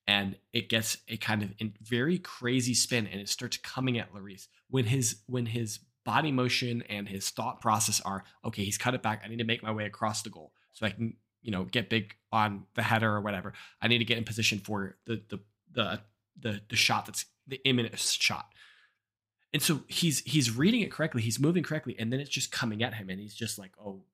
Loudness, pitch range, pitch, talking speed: -31 LUFS, 105-125 Hz, 115 Hz, 230 wpm